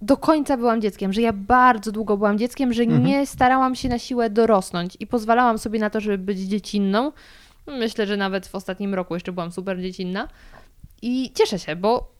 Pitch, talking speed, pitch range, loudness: 220 Hz, 190 wpm, 195-245 Hz, -21 LUFS